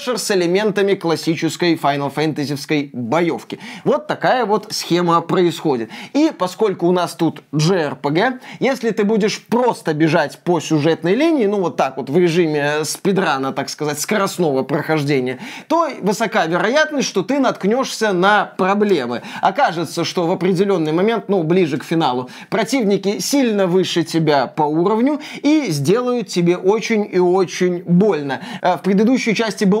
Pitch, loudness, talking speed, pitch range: 185 Hz, -17 LUFS, 140 wpm, 160-215 Hz